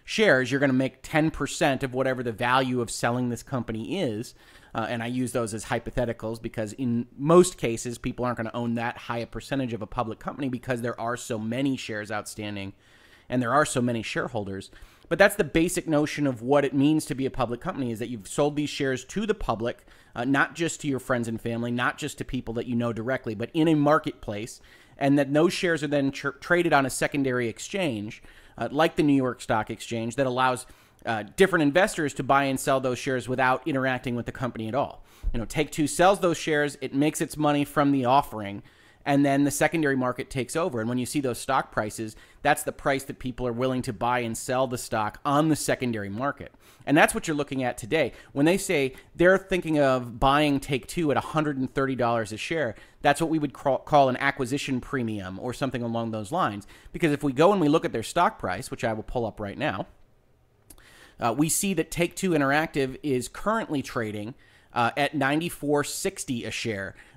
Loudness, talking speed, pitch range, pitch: -26 LUFS, 215 wpm, 115-145 Hz, 130 Hz